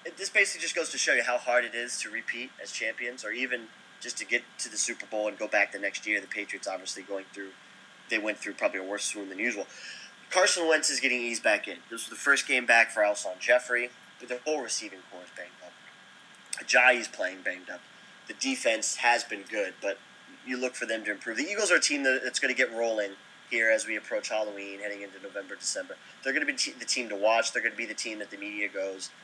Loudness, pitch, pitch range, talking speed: -28 LUFS, 115 Hz, 105-130 Hz, 250 wpm